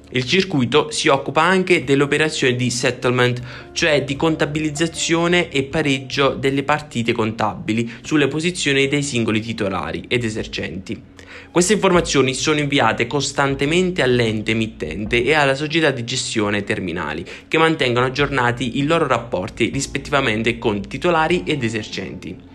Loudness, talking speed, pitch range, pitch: -18 LUFS, 125 wpm, 120-155 Hz, 135 Hz